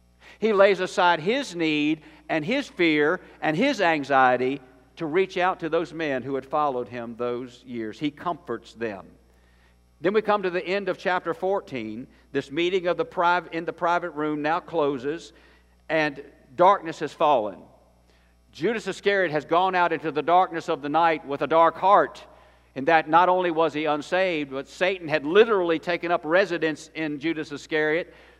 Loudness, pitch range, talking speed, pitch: -24 LUFS, 140-180 Hz, 175 wpm, 160 Hz